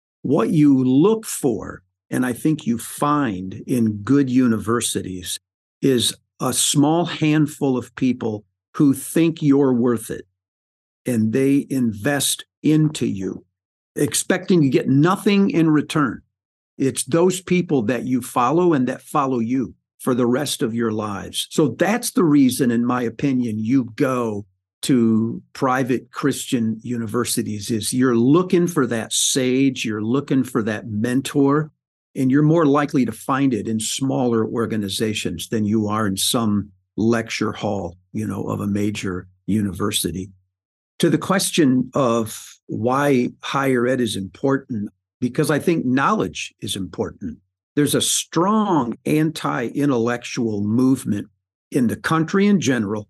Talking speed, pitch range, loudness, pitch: 140 wpm, 105-145 Hz, -20 LUFS, 125 Hz